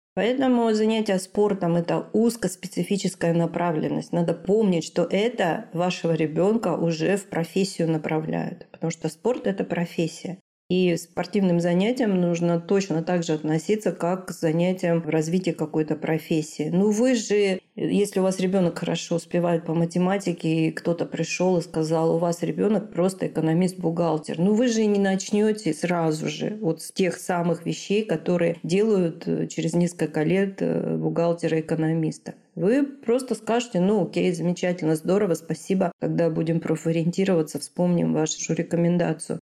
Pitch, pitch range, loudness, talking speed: 175 Hz, 165-195 Hz, -24 LUFS, 135 wpm